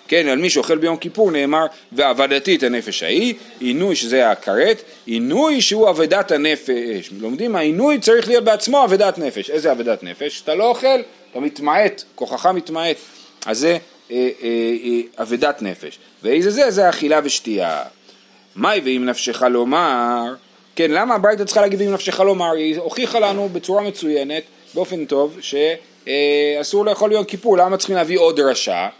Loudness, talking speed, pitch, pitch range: -17 LUFS, 160 wpm, 165 Hz, 140-210 Hz